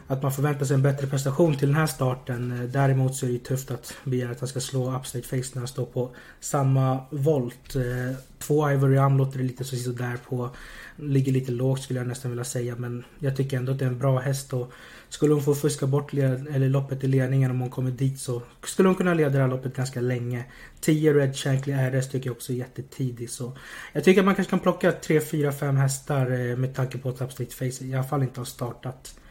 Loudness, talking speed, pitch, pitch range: -26 LUFS, 235 wpm, 130 Hz, 125-140 Hz